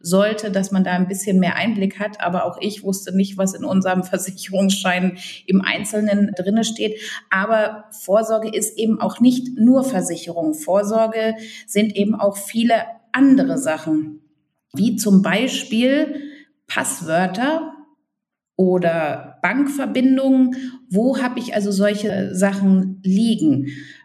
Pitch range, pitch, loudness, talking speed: 190-235 Hz, 205 Hz, -19 LUFS, 125 wpm